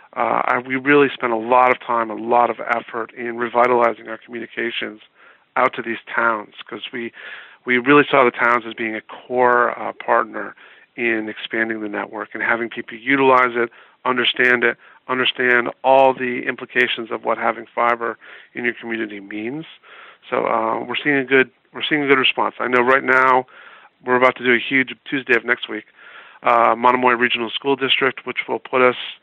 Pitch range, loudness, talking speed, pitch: 115-130 Hz, -18 LUFS, 190 wpm, 120 Hz